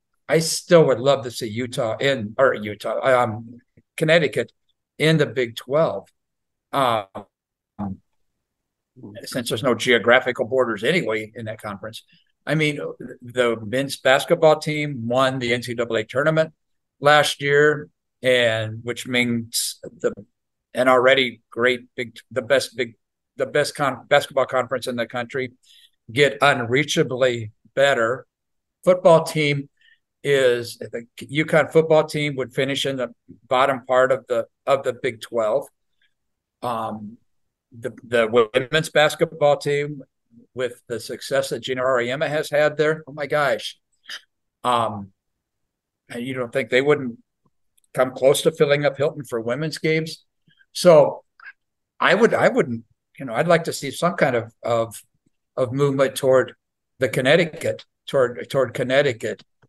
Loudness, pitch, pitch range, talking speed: -21 LUFS, 130 Hz, 120-150 Hz, 135 wpm